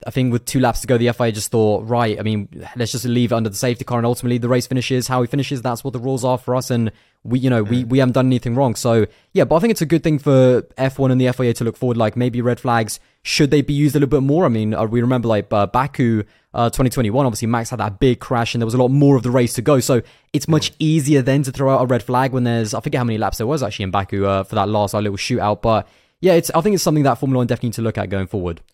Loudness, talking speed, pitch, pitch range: -18 LUFS, 315 wpm, 125 Hz, 115-135 Hz